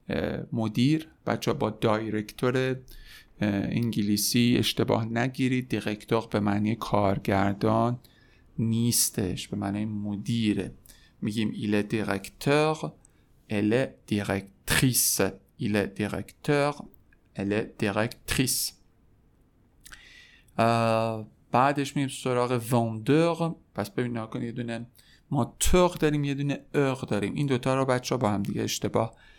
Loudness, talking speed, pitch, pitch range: -27 LUFS, 100 wpm, 115 Hz, 105-130 Hz